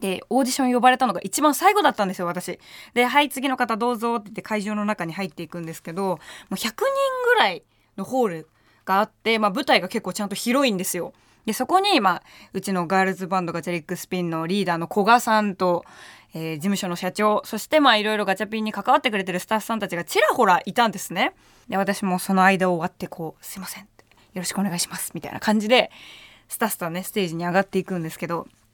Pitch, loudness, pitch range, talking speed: 195 Hz, -22 LUFS, 180-225 Hz, 480 characters per minute